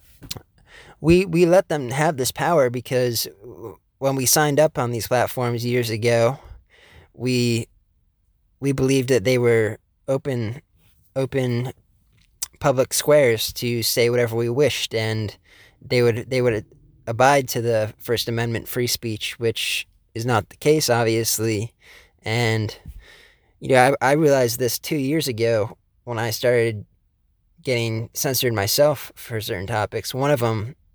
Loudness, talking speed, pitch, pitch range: -21 LUFS, 140 wpm, 120 Hz, 110-130 Hz